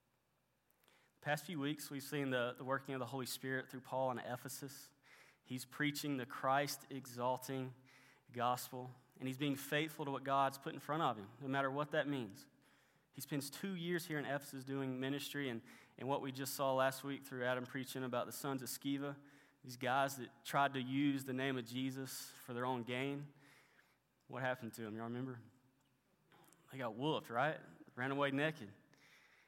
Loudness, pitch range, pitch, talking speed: -42 LUFS, 130-140 Hz, 135 Hz, 185 wpm